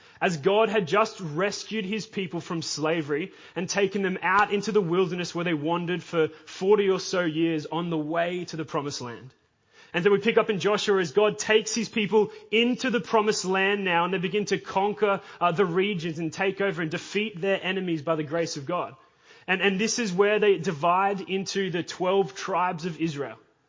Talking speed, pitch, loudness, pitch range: 205 wpm, 190 Hz, -26 LUFS, 170-205 Hz